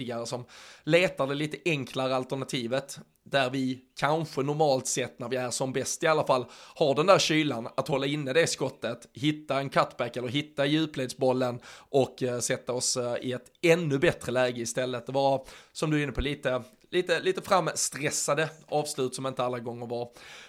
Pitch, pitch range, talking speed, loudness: 135 Hz, 125-150 Hz, 175 wpm, -28 LUFS